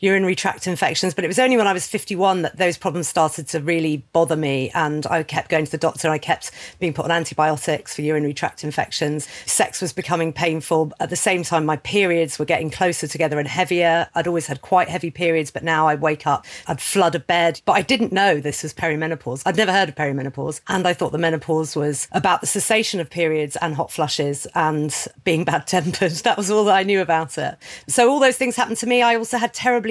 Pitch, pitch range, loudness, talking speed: 165 Hz, 155-190 Hz, -20 LUFS, 235 wpm